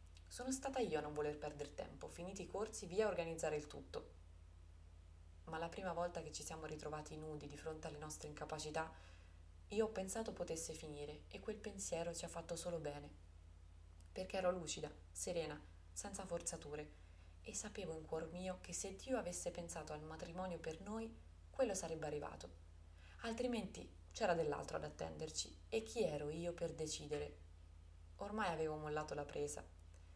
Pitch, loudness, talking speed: 155 Hz, -46 LUFS, 165 wpm